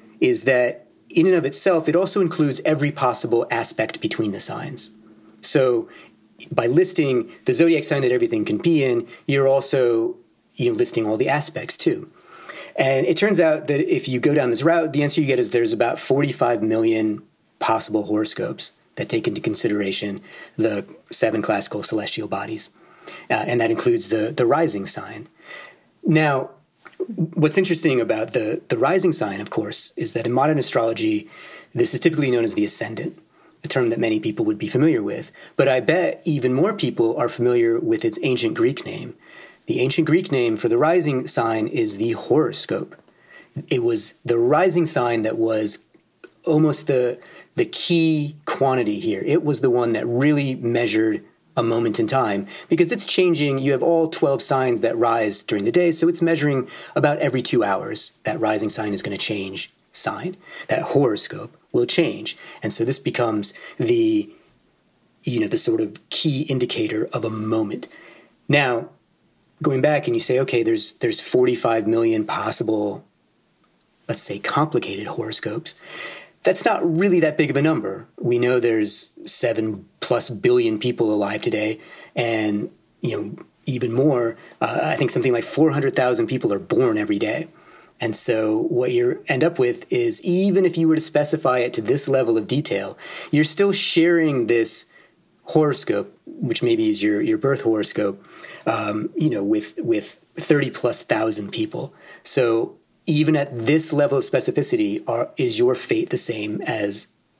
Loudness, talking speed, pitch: -21 LUFS, 170 wpm, 155 Hz